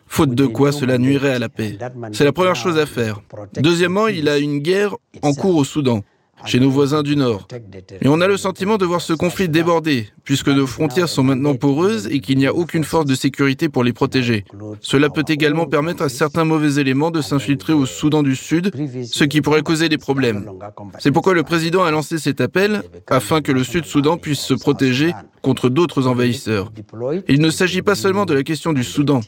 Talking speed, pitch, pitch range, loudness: 215 wpm, 145 Hz, 130-165 Hz, -17 LUFS